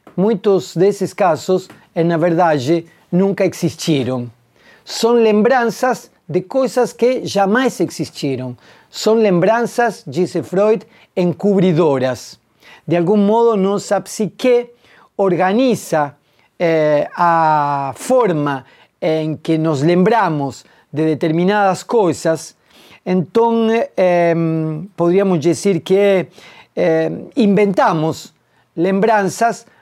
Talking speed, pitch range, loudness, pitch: 90 wpm, 160-210 Hz, -16 LUFS, 180 Hz